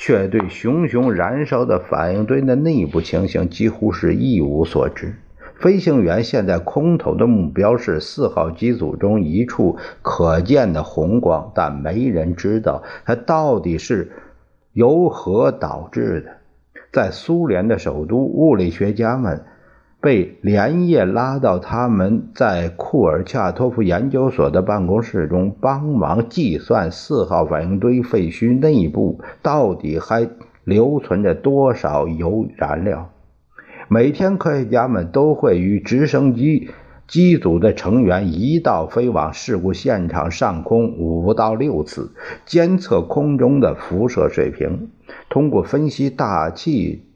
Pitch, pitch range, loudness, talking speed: 115 Hz, 95-140 Hz, -17 LUFS, 205 characters per minute